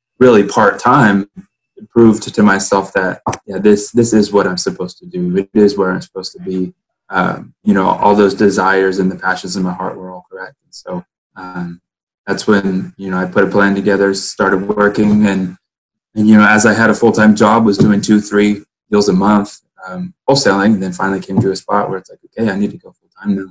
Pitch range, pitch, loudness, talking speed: 95-105 Hz, 100 Hz, -13 LUFS, 230 wpm